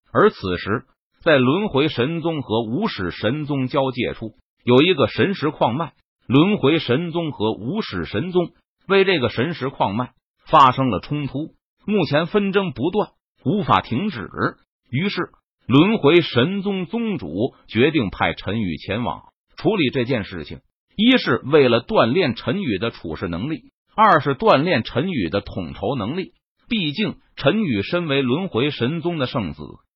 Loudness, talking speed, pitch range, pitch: -20 LUFS, 225 characters per minute, 125-180 Hz, 150 Hz